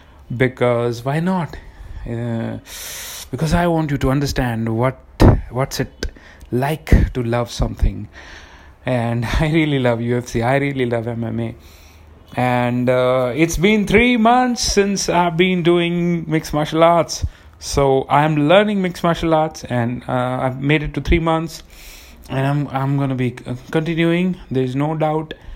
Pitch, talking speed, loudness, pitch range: 130 Hz, 150 wpm, -18 LUFS, 115-160 Hz